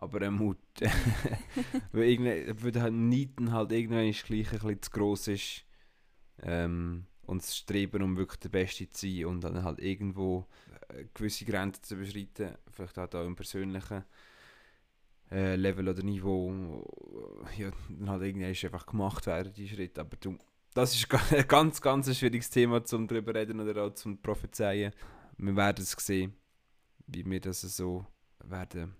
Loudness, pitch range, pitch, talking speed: -33 LUFS, 95-110 Hz, 100 Hz, 170 wpm